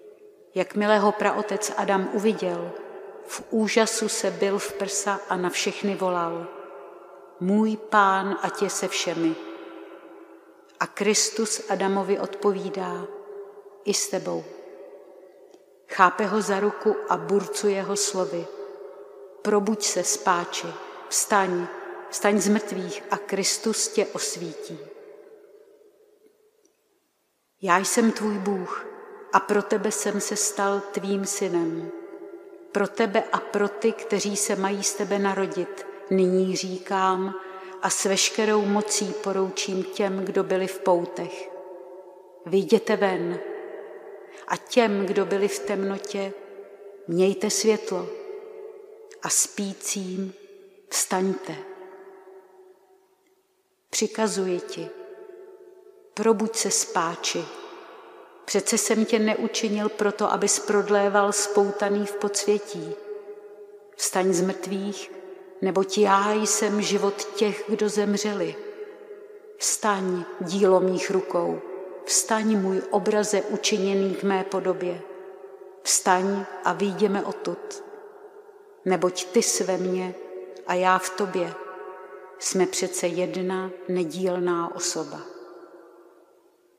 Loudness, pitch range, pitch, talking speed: -24 LUFS, 190-215 Hz, 200 Hz, 100 wpm